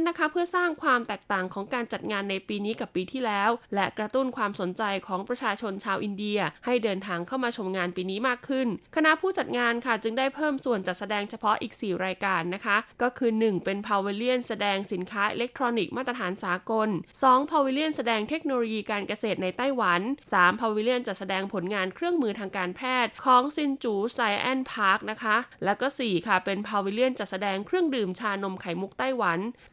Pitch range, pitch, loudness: 195-250 Hz, 215 Hz, -27 LUFS